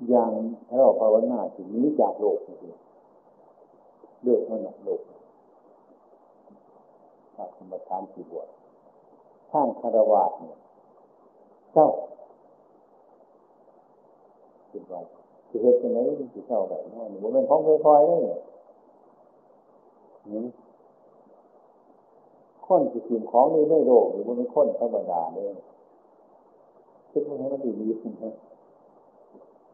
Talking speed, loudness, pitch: 300 characters per minute, -24 LUFS, 160 Hz